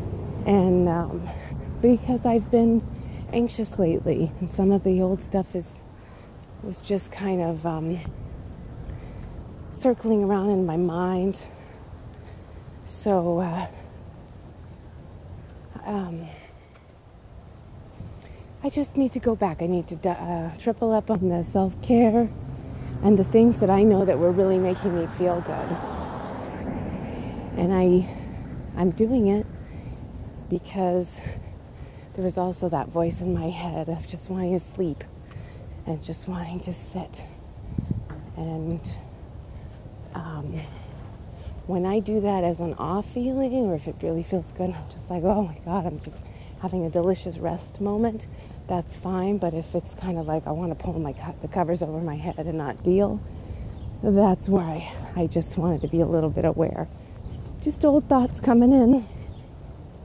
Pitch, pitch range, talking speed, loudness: 175 Hz, 125-195 Hz, 145 wpm, -25 LUFS